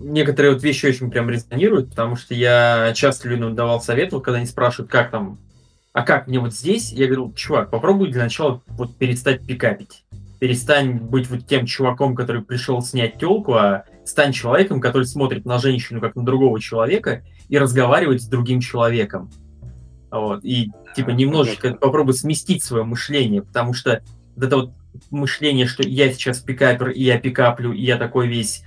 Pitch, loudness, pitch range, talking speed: 125 Hz, -19 LUFS, 115-135 Hz, 175 wpm